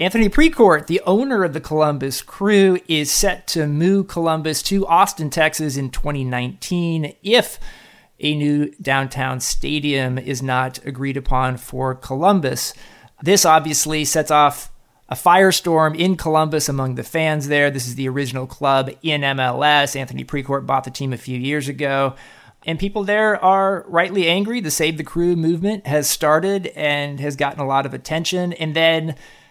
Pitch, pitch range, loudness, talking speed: 150 Hz, 135-170 Hz, -18 LUFS, 160 wpm